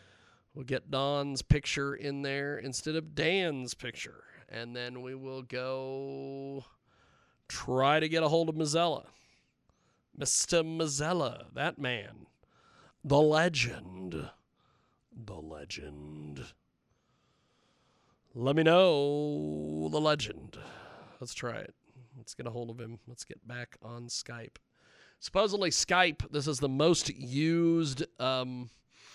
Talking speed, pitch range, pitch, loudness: 115 wpm, 120-155 Hz, 135 Hz, -31 LUFS